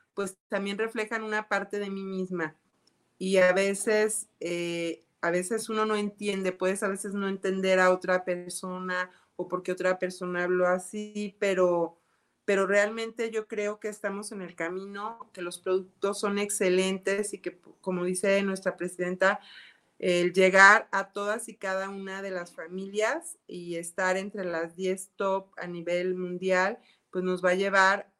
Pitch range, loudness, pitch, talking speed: 180-205 Hz, -28 LUFS, 190 Hz, 165 wpm